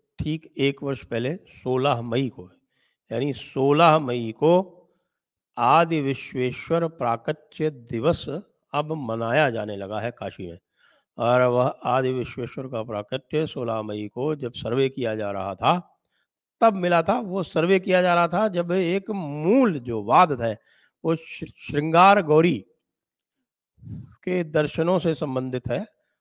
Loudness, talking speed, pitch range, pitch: -23 LUFS, 135 wpm, 120-165 Hz, 140 Hz